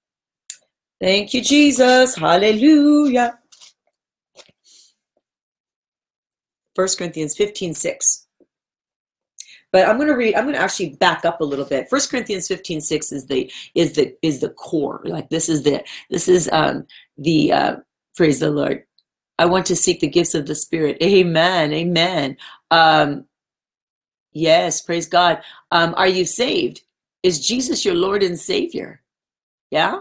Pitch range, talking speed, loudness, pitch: 160-235 Hz, 140 wpm, -17 LUFS, 180 Hz